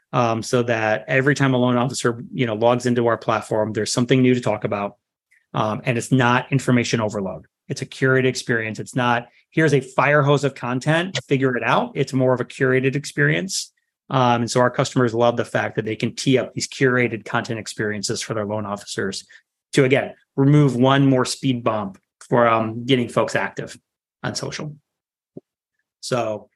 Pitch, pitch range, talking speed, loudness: 125 Hz, 115-135 Hz, 190 wpm, -20 LUFS